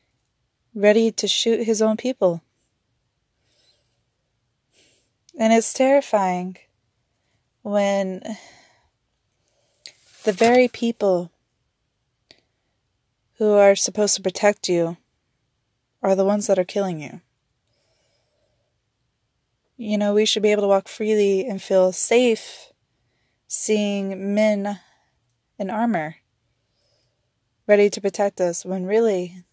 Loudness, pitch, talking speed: -20 LUFS, 190 Hz, 100 wpm